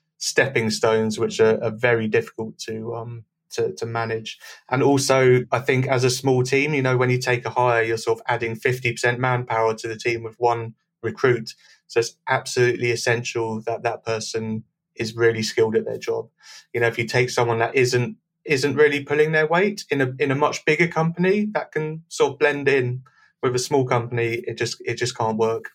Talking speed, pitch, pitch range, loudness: 205 wpm, 125 Hz, 115-145 Hz, -22 LUFS